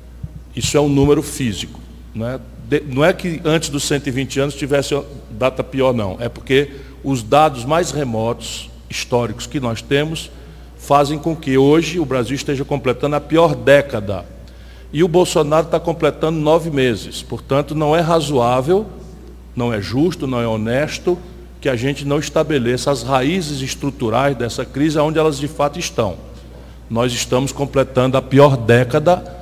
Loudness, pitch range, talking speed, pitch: -17 LUFS, 120-150 Hz, 155 wpm, 140 Hz